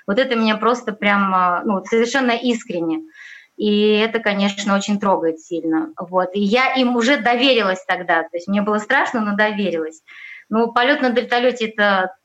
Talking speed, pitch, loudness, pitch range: 160 wpm, 210 Hz, -18 LUFS, 185-235 Hz